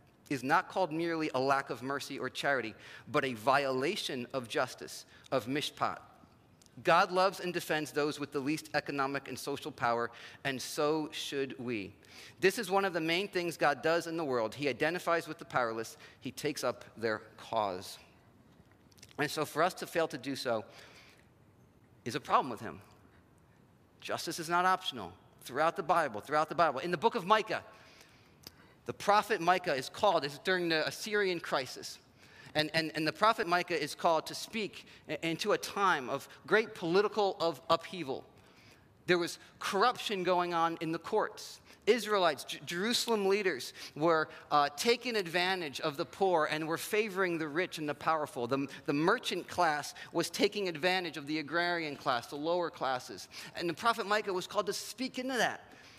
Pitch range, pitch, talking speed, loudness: 140-185 Hz, 165 Hz, 175 wpm, -33 LUFS